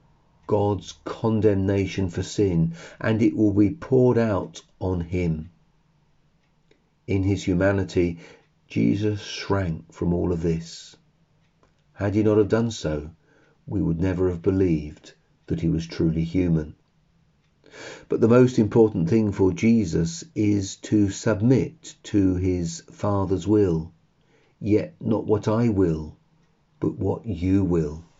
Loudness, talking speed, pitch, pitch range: -23 LUFS, 130 wpm, 100 Hz, 85-110 Hz